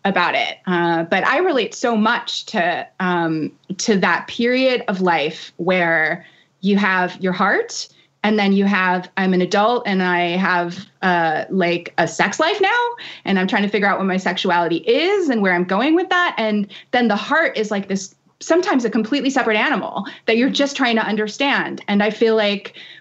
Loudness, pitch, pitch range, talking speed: -18 LUFS, 205 Hz, 180-240 Hz, 195 wpm